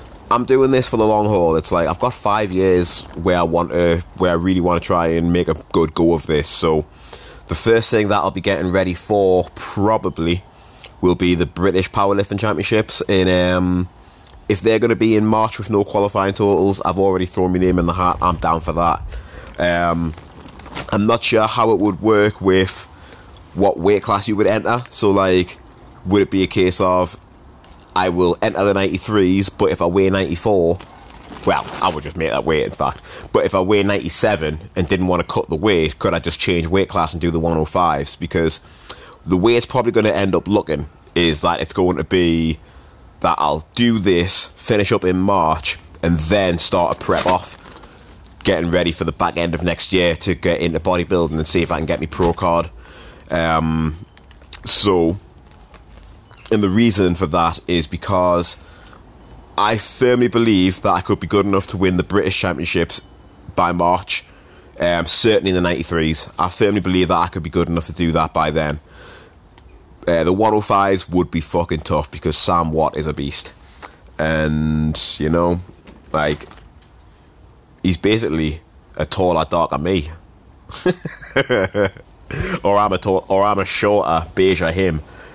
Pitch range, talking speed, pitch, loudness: 85-100 Hz, 185 wpm, 90 Hz, -17 LUFS